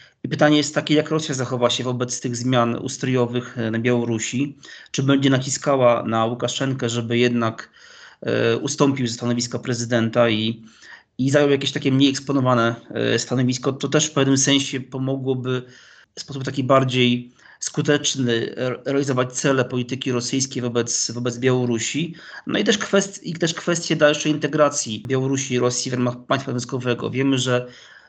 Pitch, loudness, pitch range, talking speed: 130 Hz, -21 LUFS, 120-140 Hz, 150 wpm